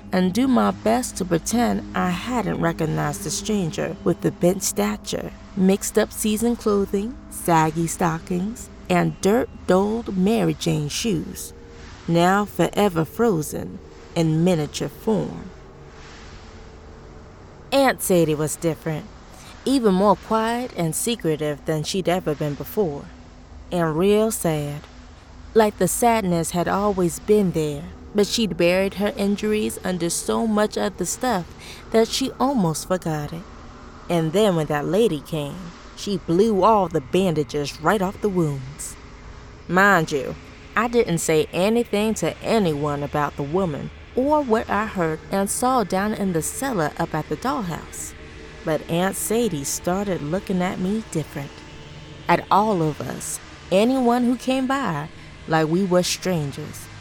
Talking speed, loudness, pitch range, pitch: 140 wpm, -22 LUFS, 155-210 Hz, 180 Hz